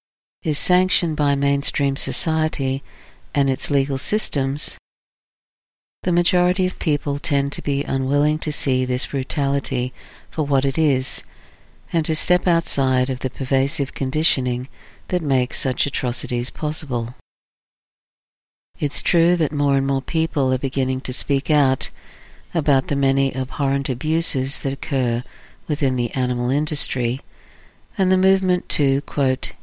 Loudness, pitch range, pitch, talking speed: -20 LUFS, 130-155 Hz, 140 Hz, 135 wpm